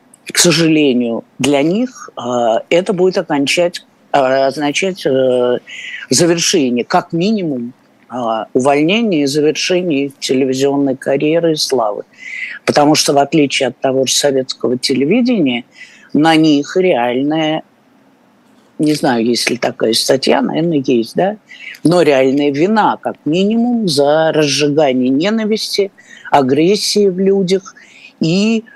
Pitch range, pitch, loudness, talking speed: 135-190 Hz, 155 Hz, -13 LUFS, 105 wpm